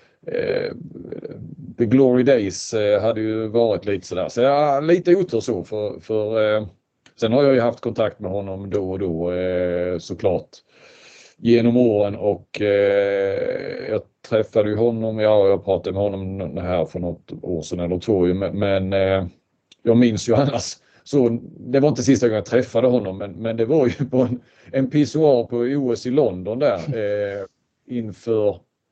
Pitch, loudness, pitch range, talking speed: 115 Hz, -20 LUFS, 100-140 Hz, 170 wpm